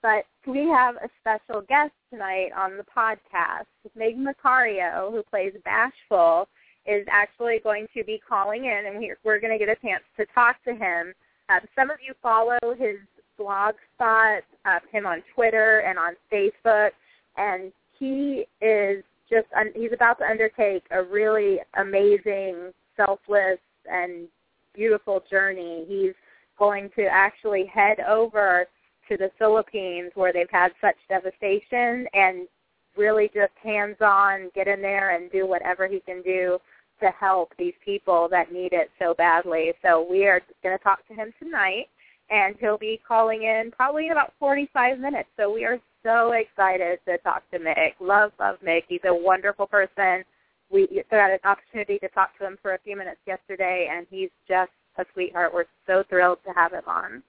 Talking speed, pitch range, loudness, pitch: 170 wpm, 190-225 Hz, -23 LUFS, 205 Hz